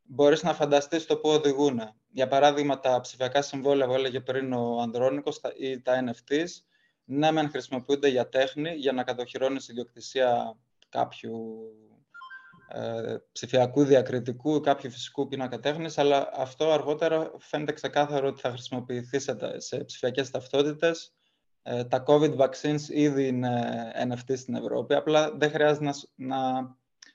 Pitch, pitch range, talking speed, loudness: 135 Hz, 125-150 Hz, 140 wpm, -27 LUFS